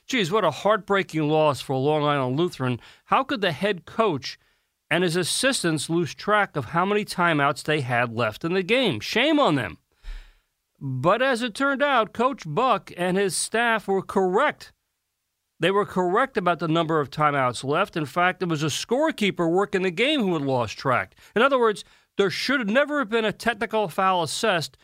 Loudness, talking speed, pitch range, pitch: -23 LUFS, 195 wpm, 155-220 Hz, 185 Hz